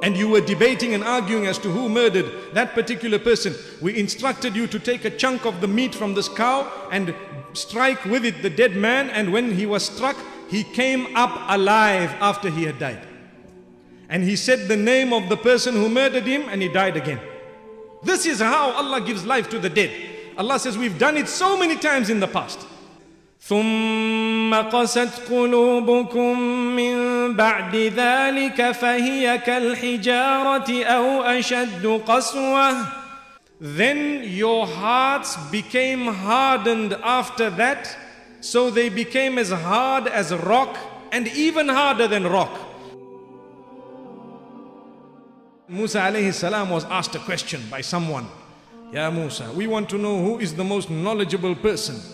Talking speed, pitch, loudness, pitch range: 150 wpm, 230 Hz, -21 LUFS, 200-245 Hz